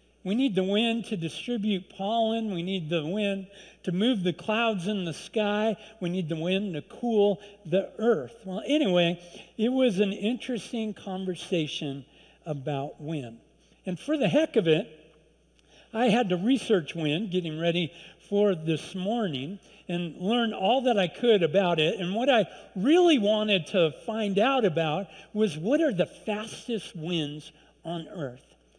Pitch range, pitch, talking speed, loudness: 170-225 Hz, 195 Hz, 160 wpm, -27 LUFS